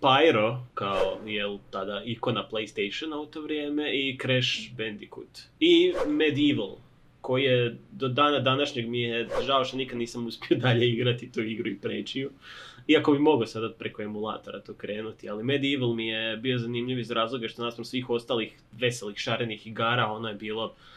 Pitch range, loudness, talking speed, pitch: 110-135 Hz, -27 LUFS, 170 wpm, 120 Hz